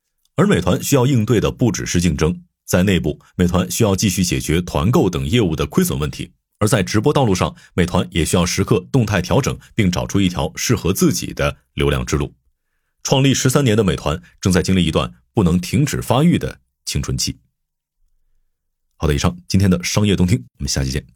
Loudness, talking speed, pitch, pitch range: -18 LUFS, 300 characters per minute, 90 Hz, 75-105 Hz